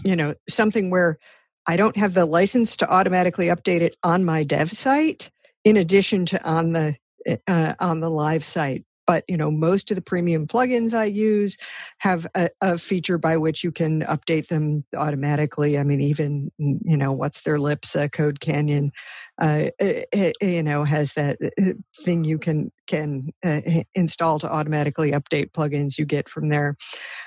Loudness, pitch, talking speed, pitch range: -22 LUFS, 165 Hz, 175 wpm, 150-185 Hz